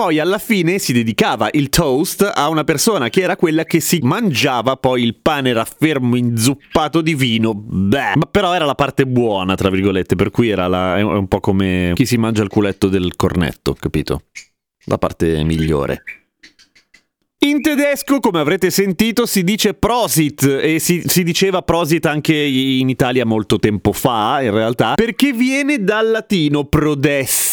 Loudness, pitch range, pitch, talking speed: -15 LUFS, 110-180 Hz, 140 Hz, 170 wpm